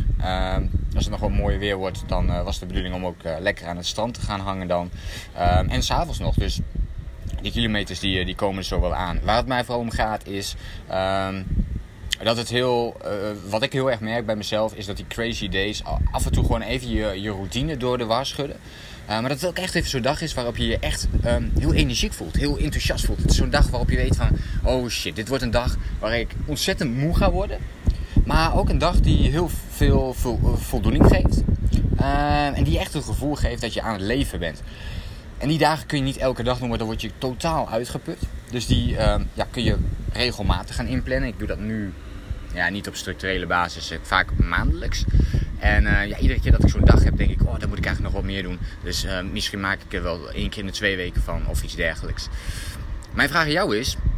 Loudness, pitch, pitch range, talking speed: -23 LUFS, 100 Hz, 90-115 Hz, 240 wpm